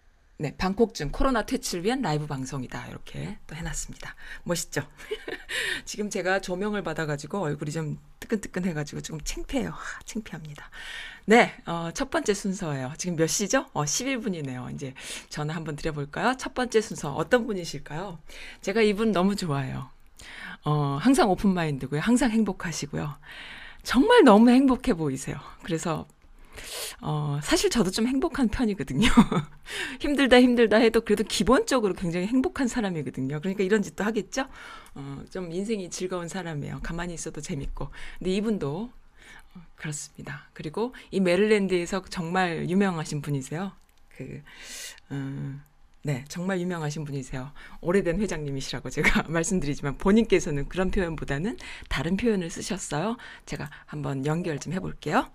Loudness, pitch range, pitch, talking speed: -26 LUFS, 150-220 Hz, 185 Hz, 345 characters per minute